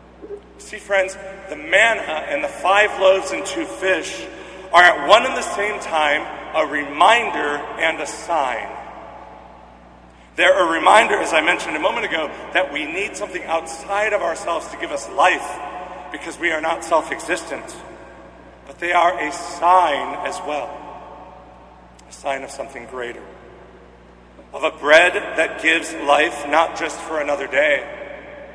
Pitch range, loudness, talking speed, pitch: 140-190 Hz, -18 LUFS, 150 wpm, 175 Hz